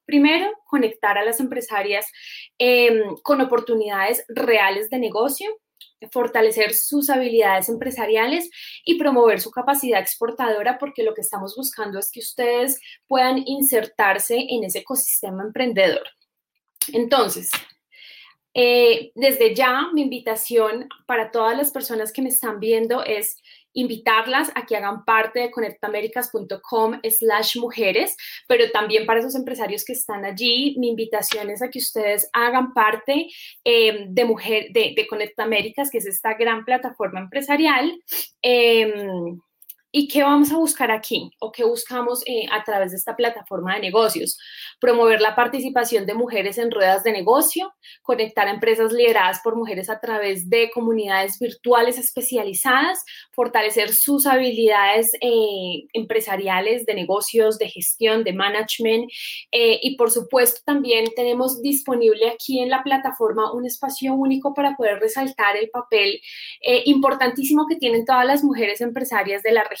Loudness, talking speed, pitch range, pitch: -20 LUFS, 140 wpm, 220-265 Hz, 235 Hz